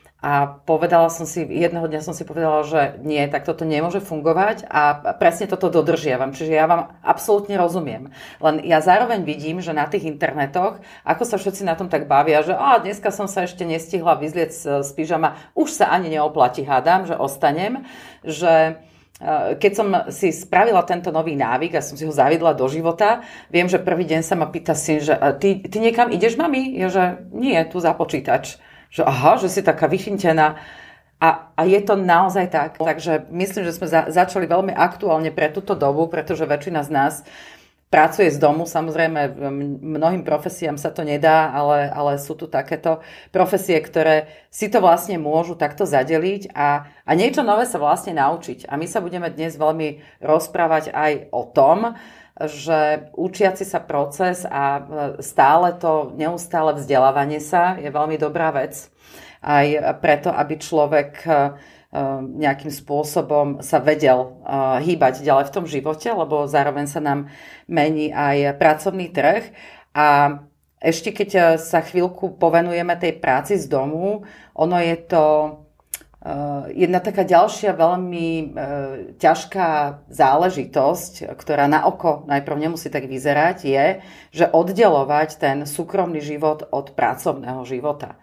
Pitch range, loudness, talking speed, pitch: 150-180 Hz, -19 LUFS, 155 wpm, 160 Hz